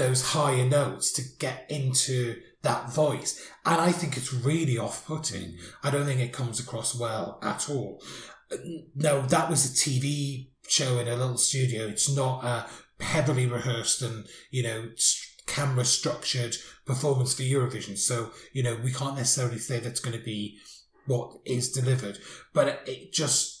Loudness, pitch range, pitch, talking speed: -27 LUFS, 120-145 Hz, 130 Hz, 160 wpm